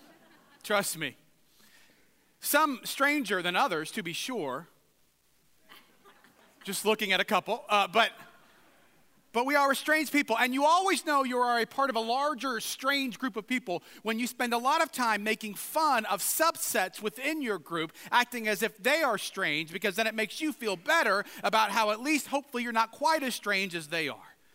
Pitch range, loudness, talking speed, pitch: 205-280 Hz, -29 LUFS, 190 wpm, 230 Hz